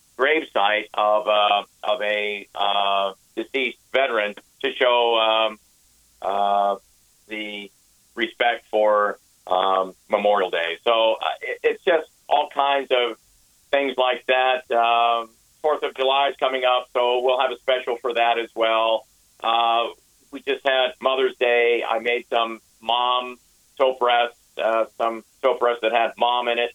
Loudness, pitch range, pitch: -21 LUFS, 105-125 Hz, 115 Hz